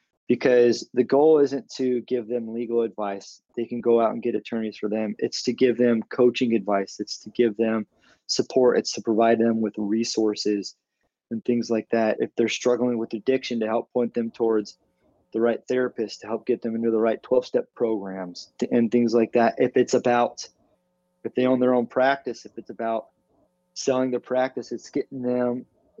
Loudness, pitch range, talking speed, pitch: -24 LUFS, 110-125 Hz, 195 wpm, 115 Hz